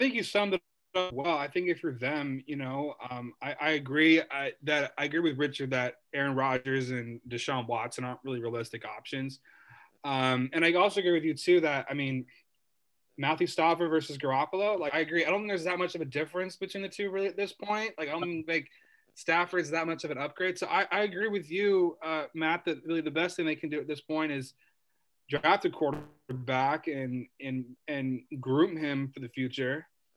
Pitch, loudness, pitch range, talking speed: 155 Hz, -31 LUFS, 135-175 Hz, 220 wpm